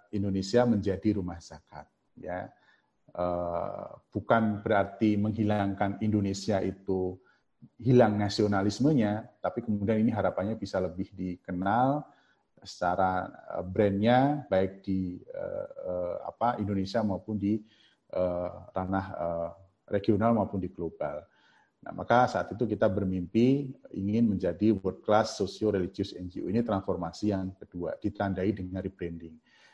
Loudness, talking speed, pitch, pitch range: -30 LUFS, 105 wpm, 100 Hz, 95-110 Hz